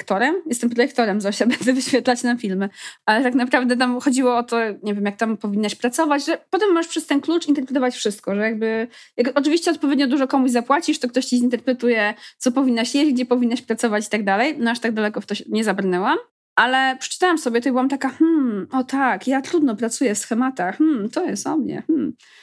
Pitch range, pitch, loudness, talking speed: 225-285 Hz, 250 Hz, -20 LUFS, 215 wpm